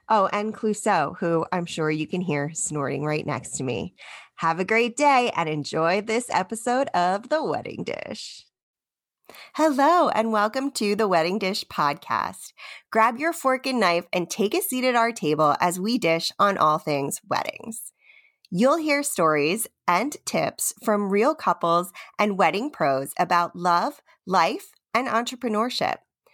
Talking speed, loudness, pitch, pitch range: 155 wpm, -23 LUFS, 205 Hz, 170-245 Hz